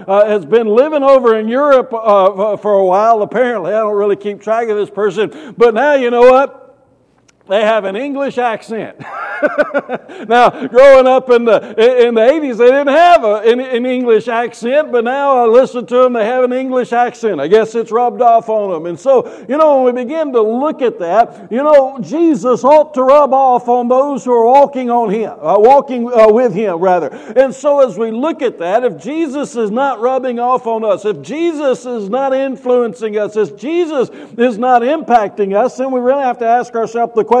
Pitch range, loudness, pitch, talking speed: 225-270 Hz, -12 LUFS, 245 Hz, 210 wpm